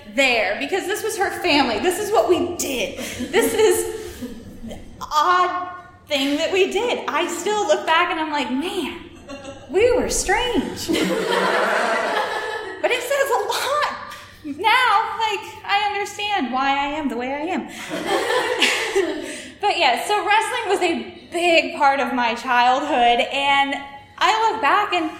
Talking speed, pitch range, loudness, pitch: 150 wpm, 285-415 Hz, -20 LUFS, 350 Hz